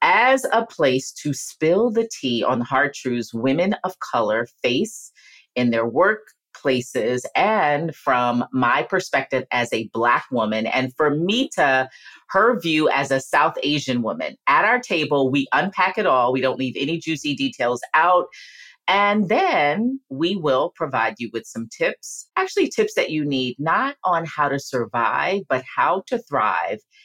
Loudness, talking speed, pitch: -21 LUFS, 160 wpm, 150 Hz